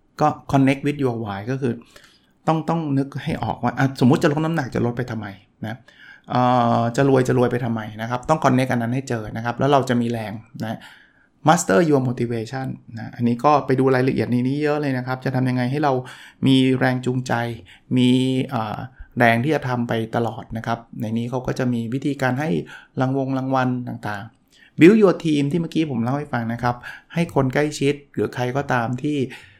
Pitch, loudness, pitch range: 125 Hz, -21 LUFS, 120-140 Hz